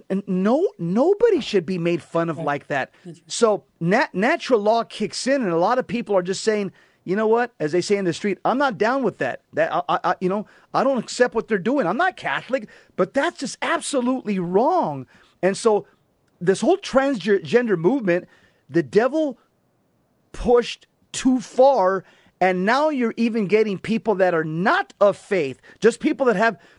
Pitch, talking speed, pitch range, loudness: 215 Hz, 190 wpm, 180-250 Hz, -21 LUFS